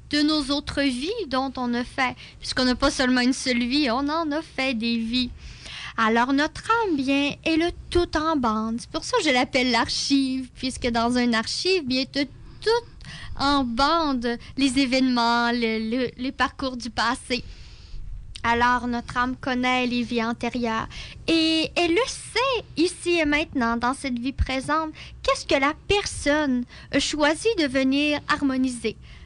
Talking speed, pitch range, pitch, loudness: 160 wpm, 245-300 Hz, 265 Hz, -23 LUFS